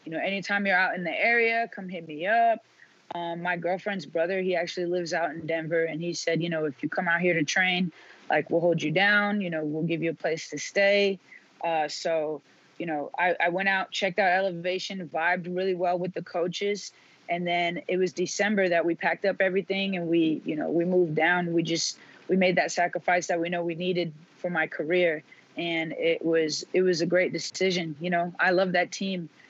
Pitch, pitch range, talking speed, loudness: 175 Hz, 165-185 Hz, 225 wpm, -26 LUFS